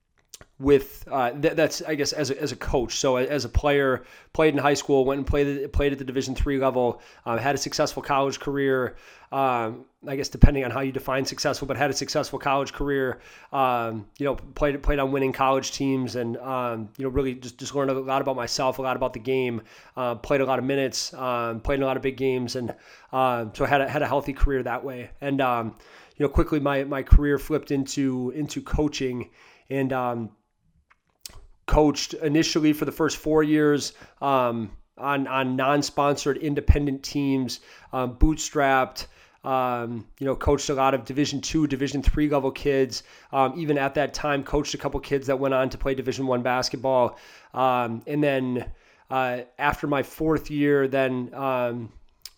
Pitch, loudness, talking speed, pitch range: 135 Hz, -25 LUFS, 195 wpm, 125-145 Hz